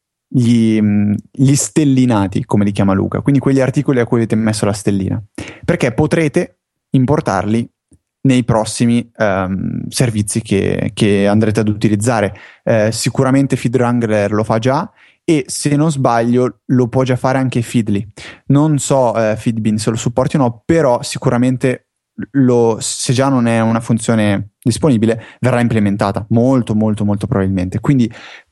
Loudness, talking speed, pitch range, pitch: -15 LUFS, 145 wpm, 110-130 Hz, 120 Hz